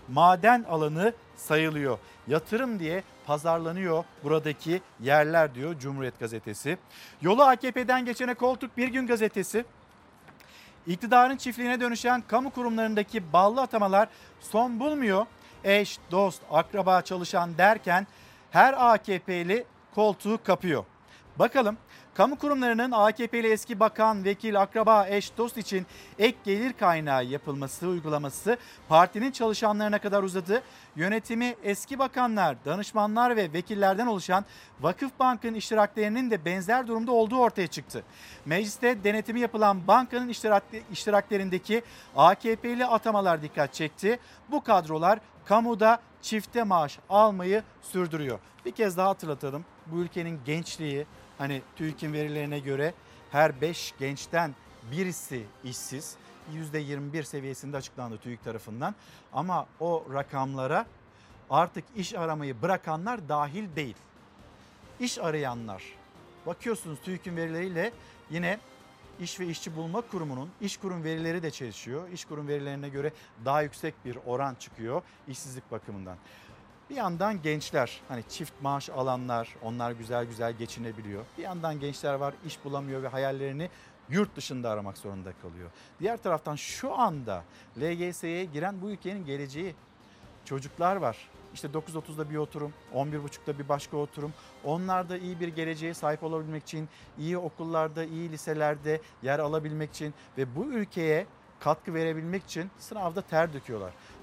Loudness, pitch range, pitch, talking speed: -28 LUFS, 145-210 Hz, 170 Hz, 120 wpm